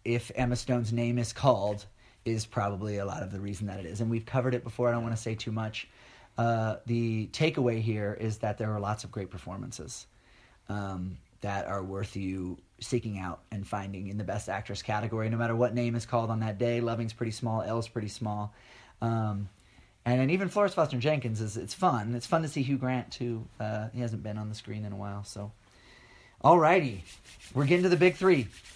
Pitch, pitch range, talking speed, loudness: 115 Hz, 100-120 Hz, 215 wpm, -31 LUFS